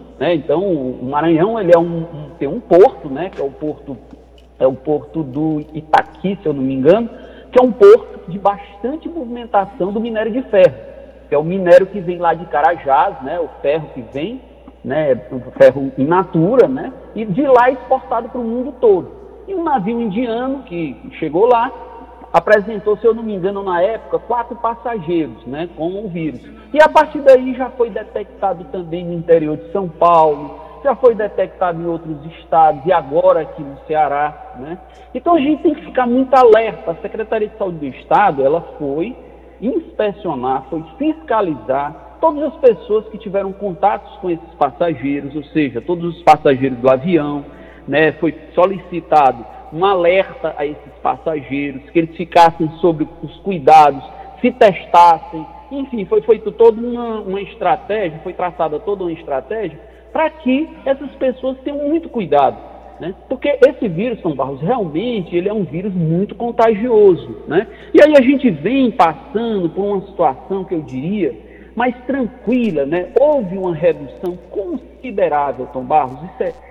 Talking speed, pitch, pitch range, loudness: 170 wpm, 195 Hz, 165-250 Hz, -16 LUFS